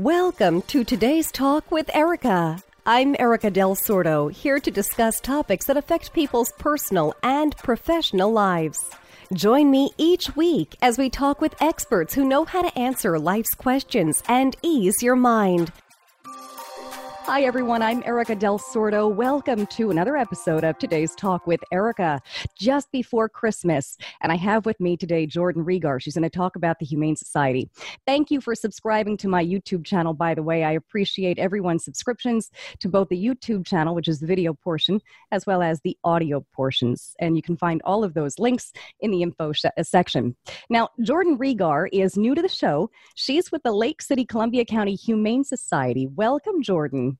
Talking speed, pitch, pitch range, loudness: 175 wpm, 210 Hz, 170-255 Hz, -22 LUFS